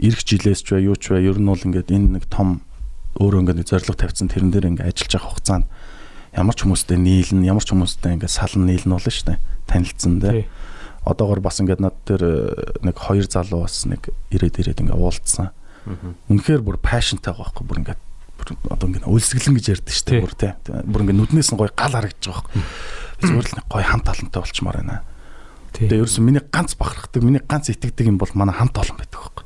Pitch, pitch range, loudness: 100 Hz, 90-110 Hz, -19 LUFS